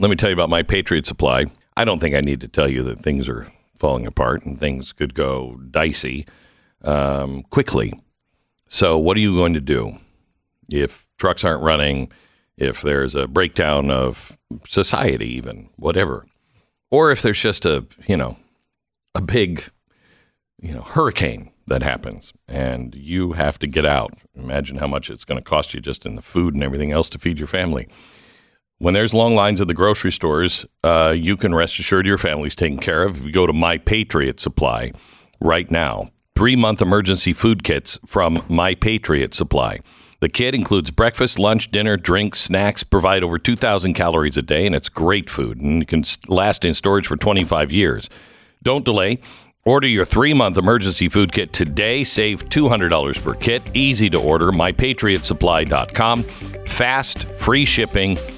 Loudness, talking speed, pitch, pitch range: -18 LUFS, 175 wpm, 90 Hz, 75-100 Hz